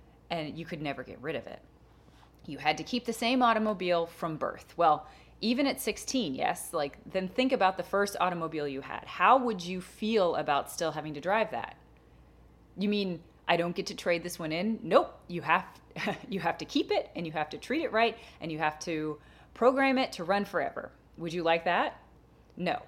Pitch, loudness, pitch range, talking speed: 180 Hz, -30 LUFS, 165-225 Hz, 210 wpm